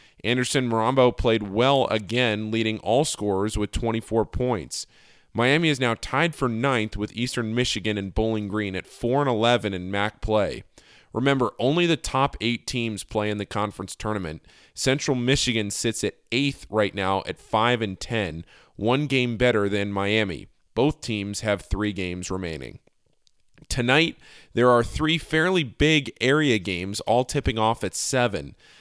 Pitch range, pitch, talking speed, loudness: 105-125 Hz, 110 Hz, 160 wpm, -24 LUFS